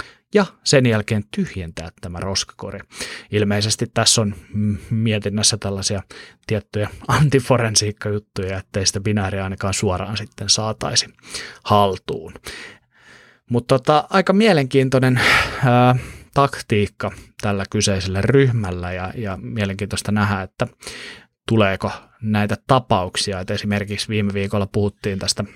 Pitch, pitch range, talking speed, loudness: 105 Hz, 100-120 Hz, 105 wpm, -19 LUFS